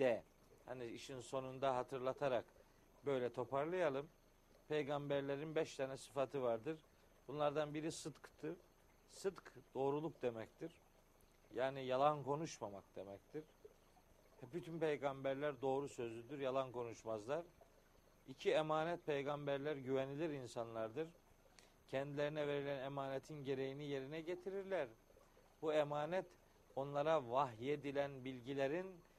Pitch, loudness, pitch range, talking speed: 140 Hz, -44 LUFS, 135-155 Hz, 90 wpm